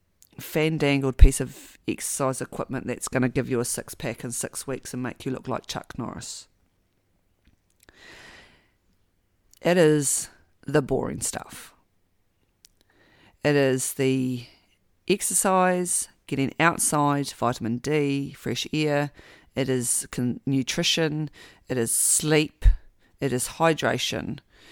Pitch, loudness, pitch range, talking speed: 130 Hz, -25 LUFS, 100-145 Hz, 120 wpm